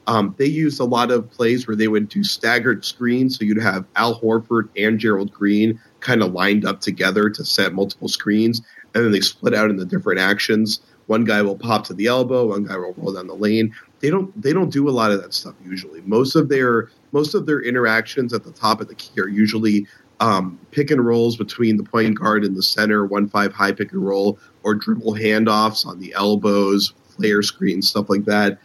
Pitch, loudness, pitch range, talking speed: 110 Hz, -19 LUFS, 100-115 Hz, 220 wpm